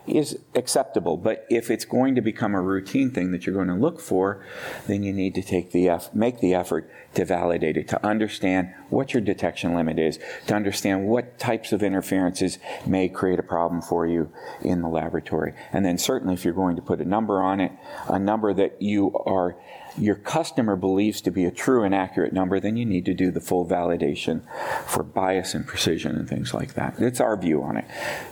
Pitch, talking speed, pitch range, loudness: 95 Hz, 210 wpm, 90-100 Hz, -24 LUFS